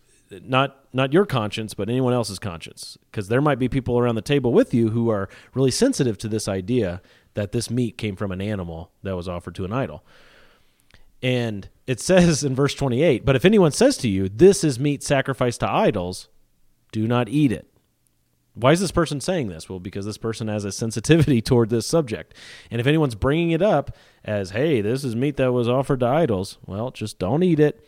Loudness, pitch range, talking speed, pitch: -21 LUFS, 105-140 Hz, 210 wpm, 120 Hz